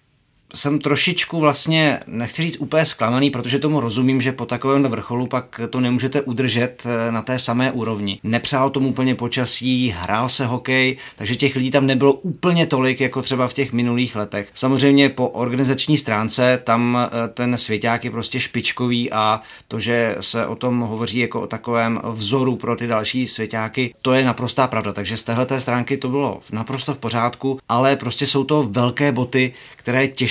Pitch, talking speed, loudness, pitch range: 125 Hz, 170 wpm, -19 LUFS, 115-135 Hz